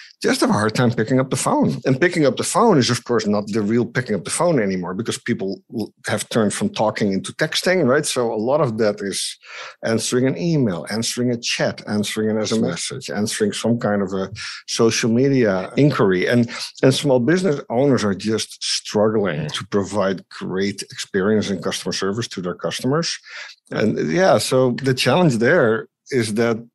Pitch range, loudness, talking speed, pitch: 105-130 Hz, -19 LUFS, 190 wpm, 115 Hz